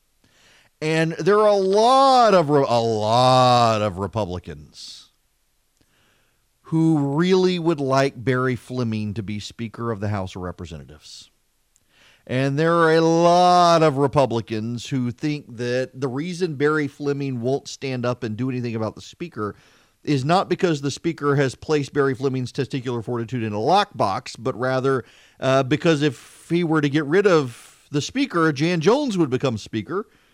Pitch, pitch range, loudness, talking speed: 135 Hz, 115-160 Hz, -21 LUFS, 155 wpm